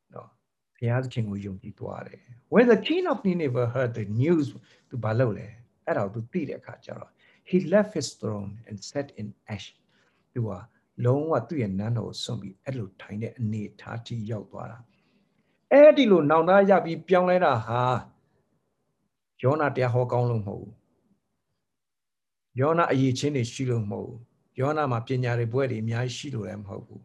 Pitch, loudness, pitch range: 120 Hz, -25 LUFS, 110-145 Hz